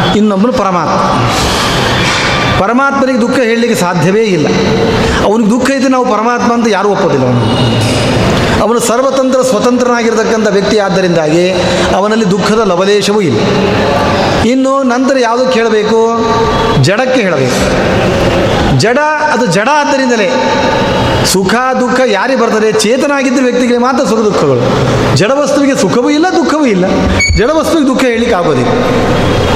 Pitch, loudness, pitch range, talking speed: 235 Hz, -9 LUFS, 205-260 Hz, 110 wpm